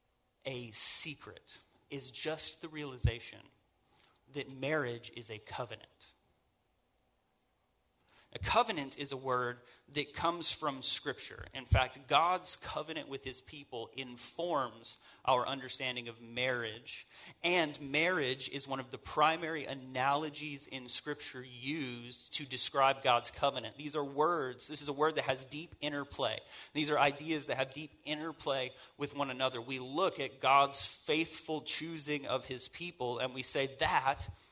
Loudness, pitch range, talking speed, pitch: -35 LUFS, 125-150 Hz, 140 wpm, 135 Hz